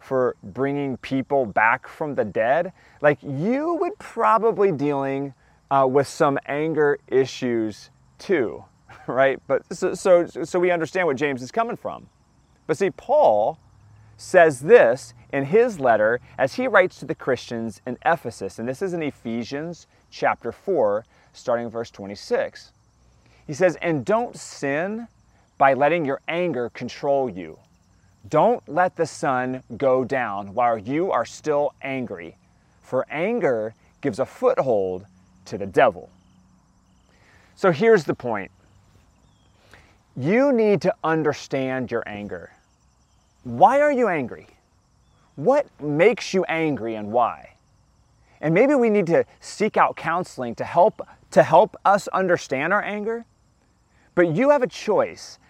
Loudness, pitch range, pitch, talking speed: -22 LUFS, 115-180 Hz, 140 Hz, 140 wpm